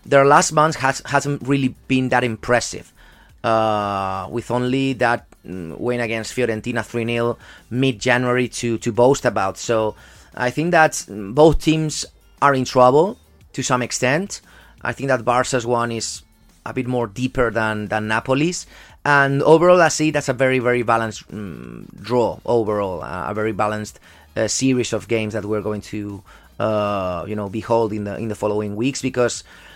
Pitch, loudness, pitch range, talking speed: 120 Hz, -19 LUFS, 105-130 Hz, 170 wpm